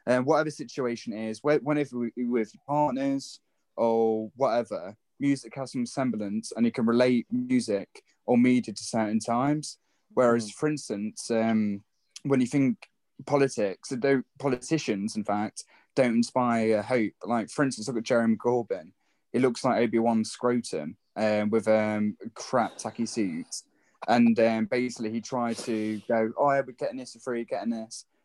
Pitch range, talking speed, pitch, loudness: 110-135 Hz, 165 wpm, 120 Hz, -27 LUFS